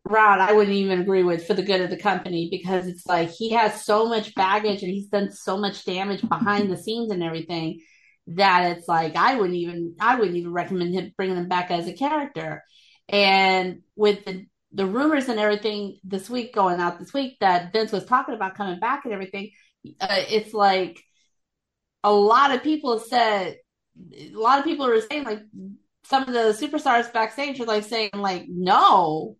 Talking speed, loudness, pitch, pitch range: 195 wpm, -22 LUFS, 200 Hz, 185-220 Hz